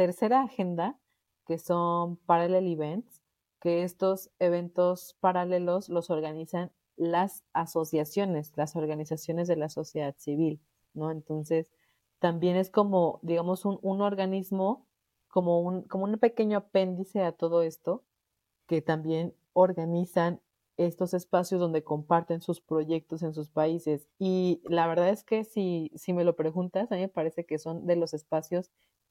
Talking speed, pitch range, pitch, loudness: 140 wpm, 160-185 Hz, 175 Hz, -29 LUFS